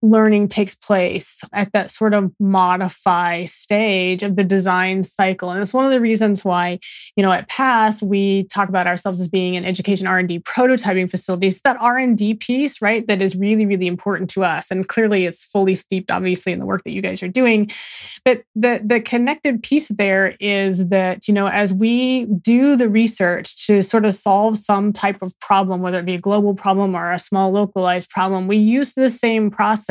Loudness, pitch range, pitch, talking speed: -17 LUFS, 185-220 Hz, 200 Hz, 200 wpm